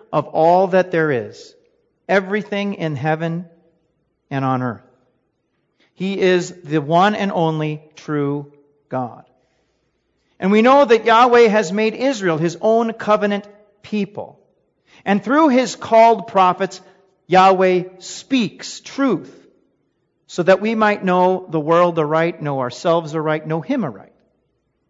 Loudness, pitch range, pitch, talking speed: -17 LUFS, 160-210 Hz, 185 Hz, 130 wpm